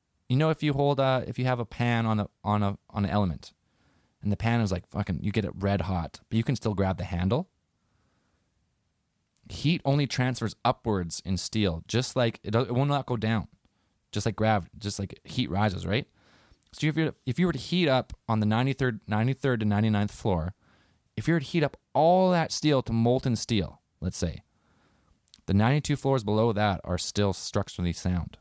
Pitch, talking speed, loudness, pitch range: 110 Hz, 205 wpm, -28 LUFS, 100-130 Hz